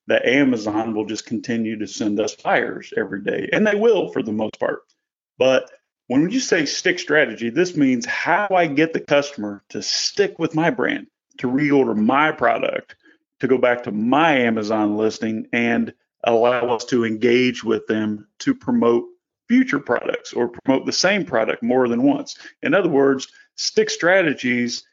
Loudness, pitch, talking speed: -20 LUFS, 135 Hz, 170 wpm